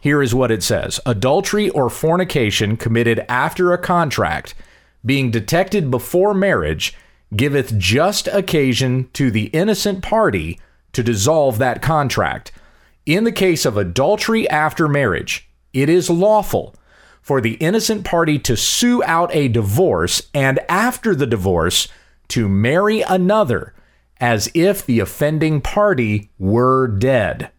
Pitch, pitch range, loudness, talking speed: 140 Hz, 115-180 Hz, -17 LUFS, 130 wpm